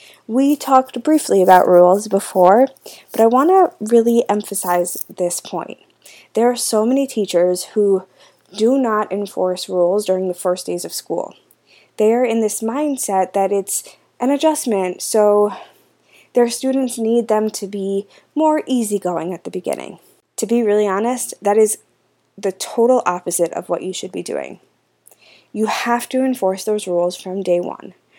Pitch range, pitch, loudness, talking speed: 185-245 Hz, 210 Hz, -17 LUFS, 160 wpm